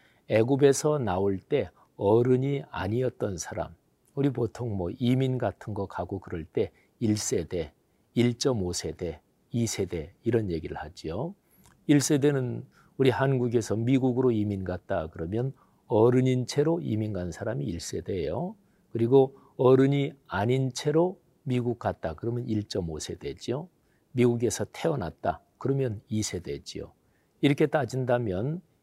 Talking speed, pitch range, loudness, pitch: 250 characters per minute, 105-135 Hz, -28 LUFS, 120 Hz